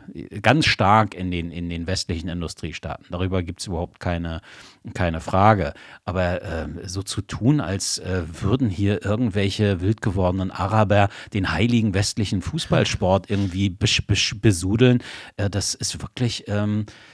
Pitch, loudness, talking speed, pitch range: 100 Hz, -22 LUFS, 140 wpm, 90-110 Hz